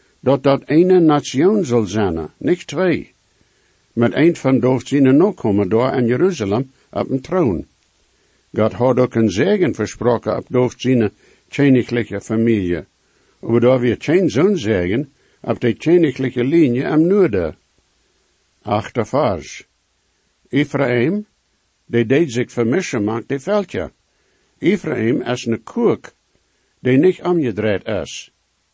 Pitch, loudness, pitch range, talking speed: 125 Hz, -17 LUFS, 115-145 Hz, 120 wpm